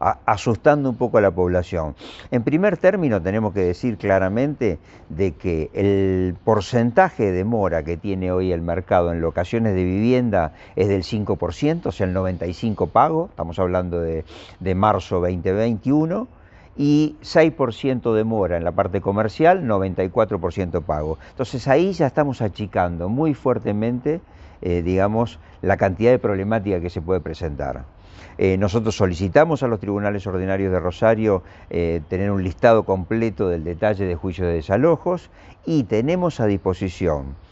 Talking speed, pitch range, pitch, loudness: 150 wpm, 90-120 Hz, 100 Hz, -21 LUFS